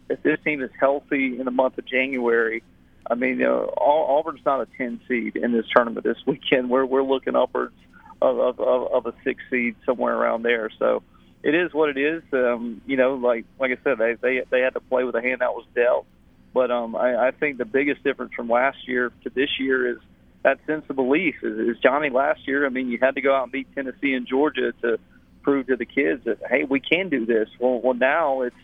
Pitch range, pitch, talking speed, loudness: 120-135 Hz, 130 Hz, 240 wpm, -23 LUFS